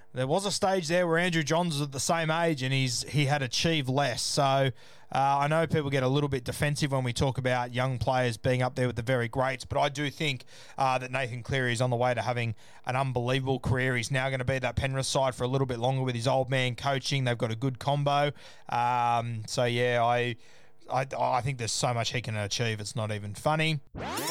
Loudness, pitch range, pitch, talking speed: -28 LUFS, 125-140 Hz, 130 Hz, 245 wpm